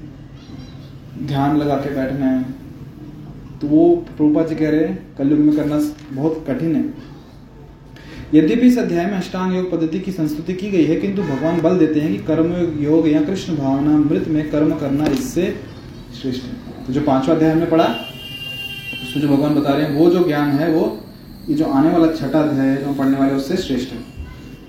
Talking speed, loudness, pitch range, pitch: 190 wpm, -18 LUFS, 135-160 Hz, 150 Hz